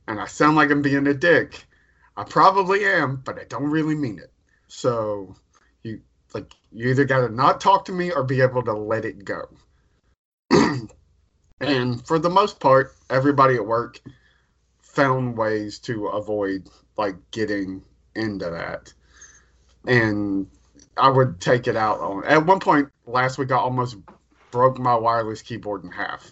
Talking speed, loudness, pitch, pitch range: 160 wpm, -21 LUFS, 125 Hz, 100-140 Hz